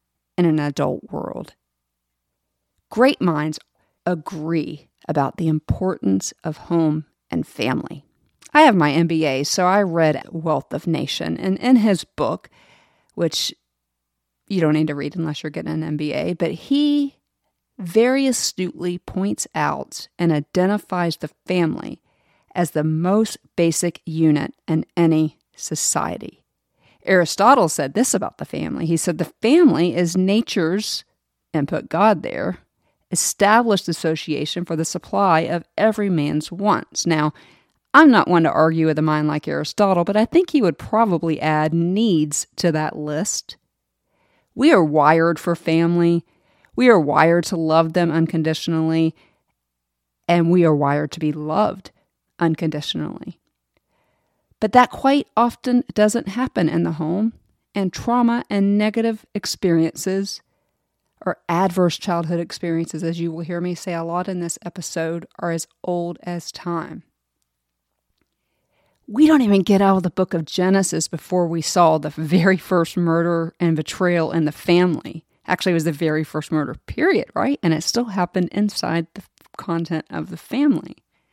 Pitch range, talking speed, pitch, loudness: 155-190 Hz, 145 wpm, 170 Hz, -20 LUFS